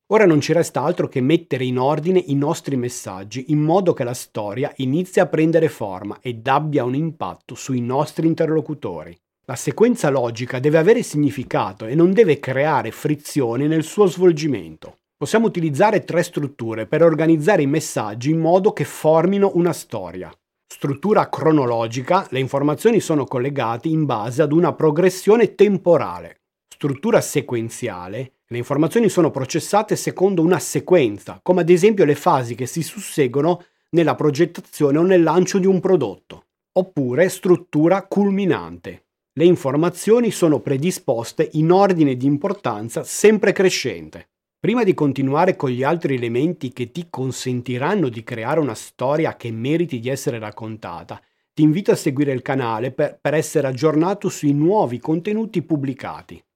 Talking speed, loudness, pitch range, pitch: 145 wpm, -19 LUFS, 130-175 Hz, 155 Hz